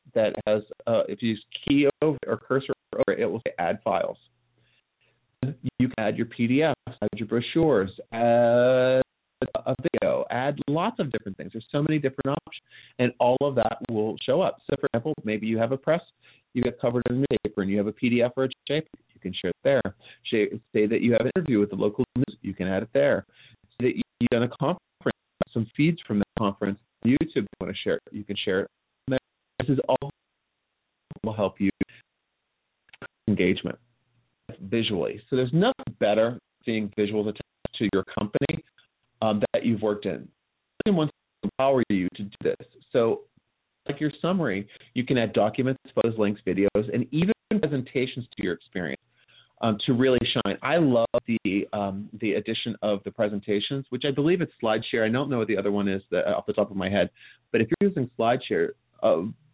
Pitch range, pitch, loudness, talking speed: 105-135 Hz, 120 Hz, -26 LUFS, 200 wpm